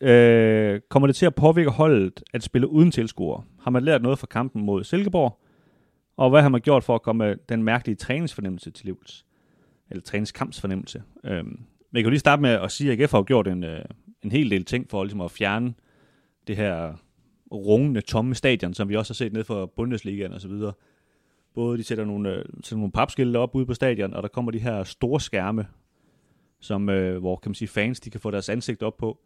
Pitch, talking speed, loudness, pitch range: 115 Hz, 205 wpm, -23 LUFS, 100-130 Hz